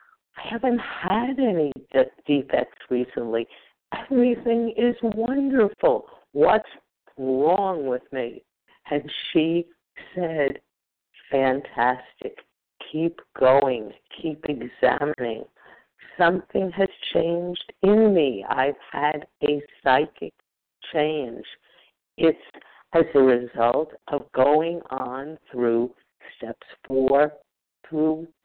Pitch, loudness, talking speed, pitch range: 155 Hz, -23 LUFS, 90 wpm, 135-190 Hz